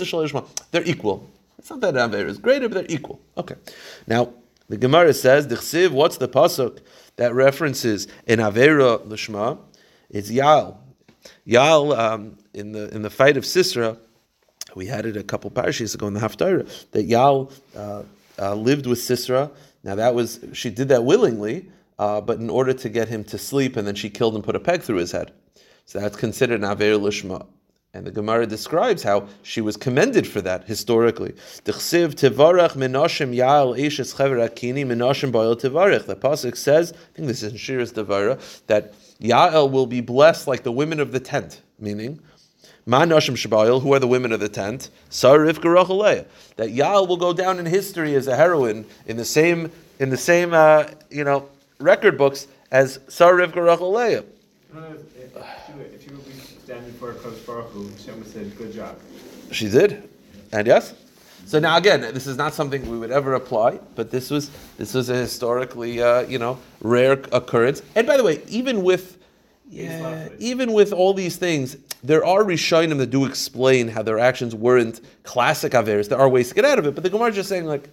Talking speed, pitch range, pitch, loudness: 170 wpm, 115-155 Hz, 130 Hz, -19 LUFS